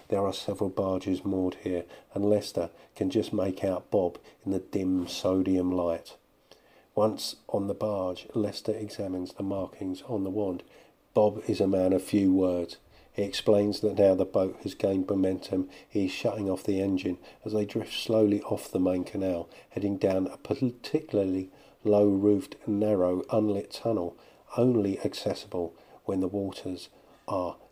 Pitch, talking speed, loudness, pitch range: 95 Hz, 160 wpm, -29 LUFS, 95-105 Hz